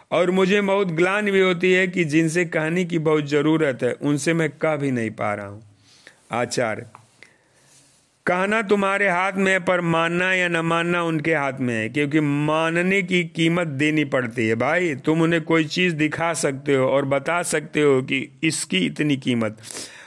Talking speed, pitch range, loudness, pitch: 180 wpm, 140-180 Hz, -21 LUFS, 160 Hz